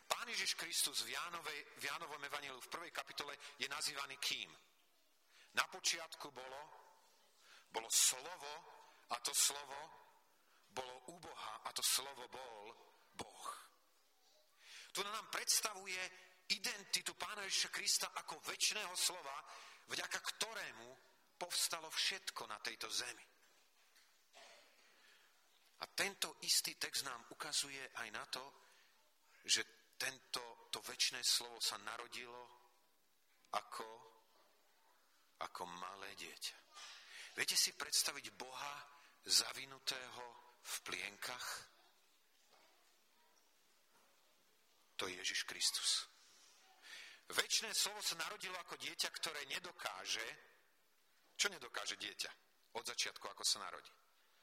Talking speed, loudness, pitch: 100 wpm, -41 LUFS, 185 Hz